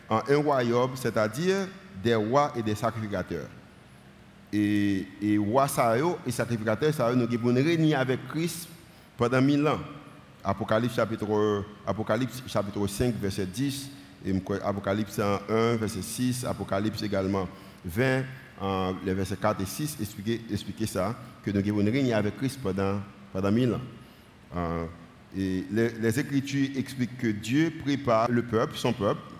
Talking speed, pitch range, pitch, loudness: 135 wpm, 100-130 Hz, 110 Hz, -28 LUFS